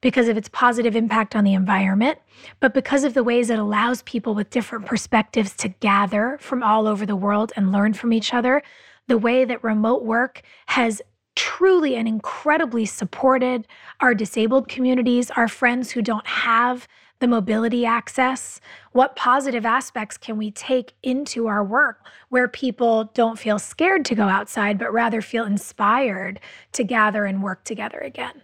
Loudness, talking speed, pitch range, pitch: -21 LUFS, 165 wpm, 215-255 Hz, 235 Hz